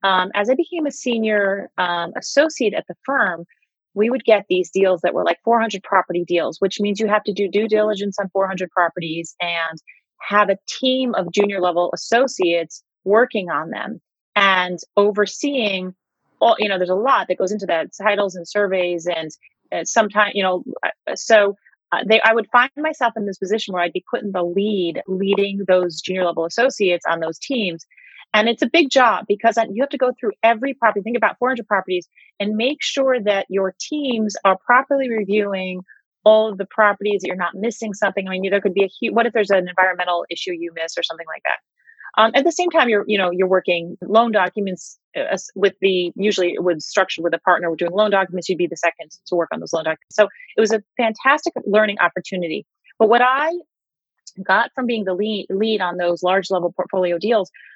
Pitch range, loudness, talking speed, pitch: 180-225 Hz, -19 LUFS, 205 wpm, 200 Hz